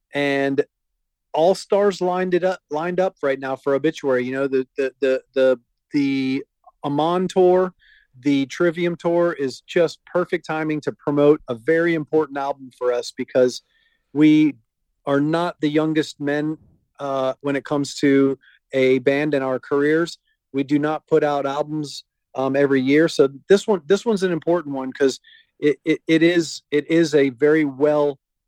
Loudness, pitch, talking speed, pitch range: -20 LUFS, 150 Hz, 170 wpm, 135-170 Hz